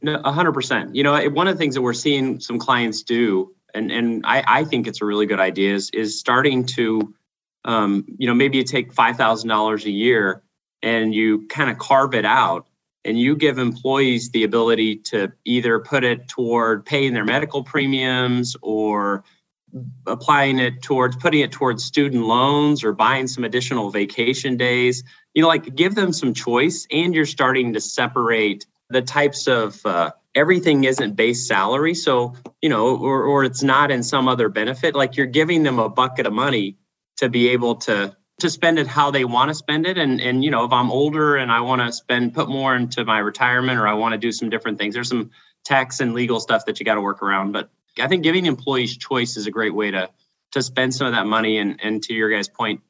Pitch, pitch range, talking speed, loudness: 125 Hz, 110-140 Hz, 210 wpm, -19 LUFS